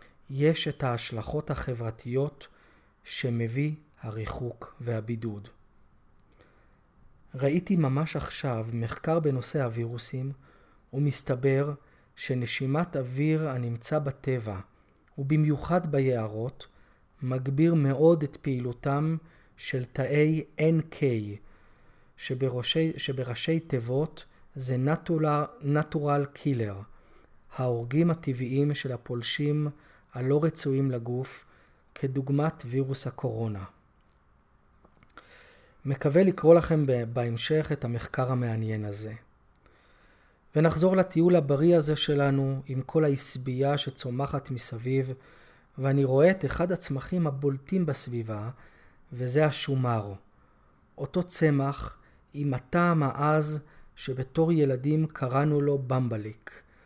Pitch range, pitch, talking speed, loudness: 125-150 Hz, 135 Hz, 85 wpm, -28 LUFS